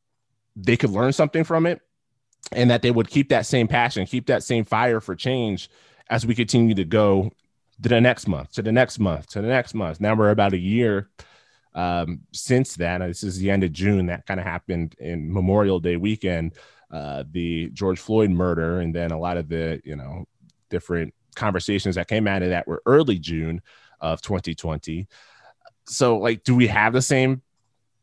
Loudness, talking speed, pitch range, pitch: -22 LUFS, 195 wpm, 90-120 Hz, 100 Hz